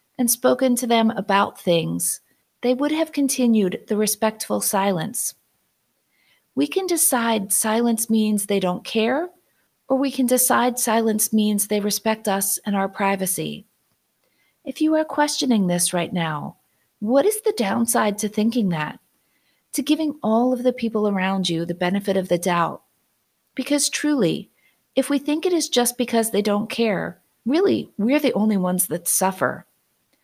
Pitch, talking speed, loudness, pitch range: 220 Hz, 155 wpm, -21 LUFS, 195-260 Hz